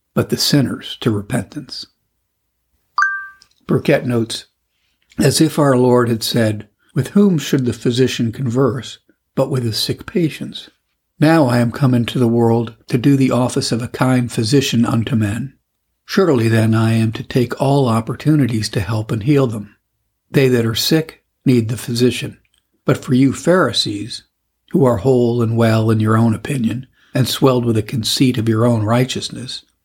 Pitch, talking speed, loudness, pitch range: 120 Hz, 165 wpm, -16 LUFS, 115-135 Hz